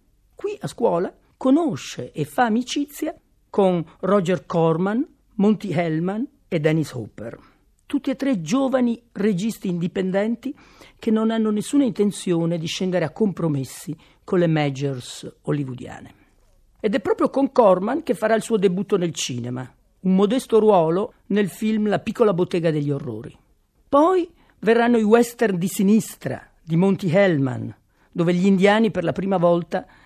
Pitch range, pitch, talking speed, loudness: 165-230 Hz, 195 Hz, 140 wpm, -21 LUFS